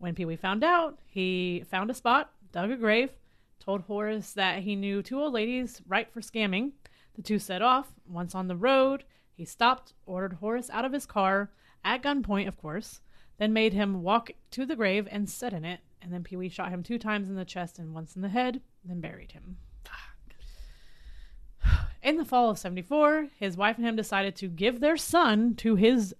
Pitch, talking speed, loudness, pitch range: 205 Hz, 205 wpm, -29 LUFS, 185-240 Hz